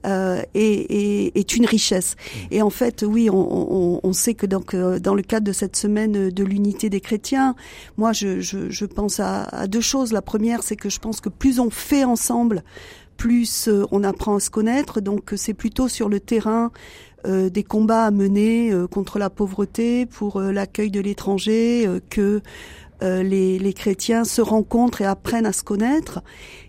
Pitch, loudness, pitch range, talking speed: 210 Hz, -21 LUFS, 195-230 Hz, 190 wpm